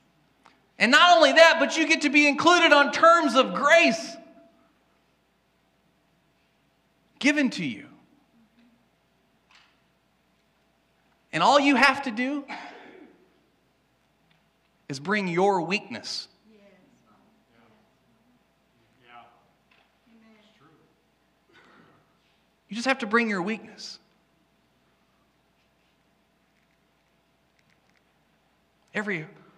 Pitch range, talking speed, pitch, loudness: 210-295 Hz, 70 wpm, 235 Hz, -21 LUFS